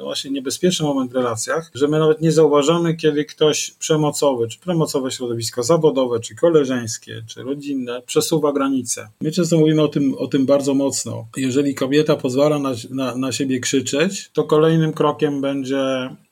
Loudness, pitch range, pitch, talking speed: -19 LUFS, 130-155 Hz, 140 Hz, 165 wpm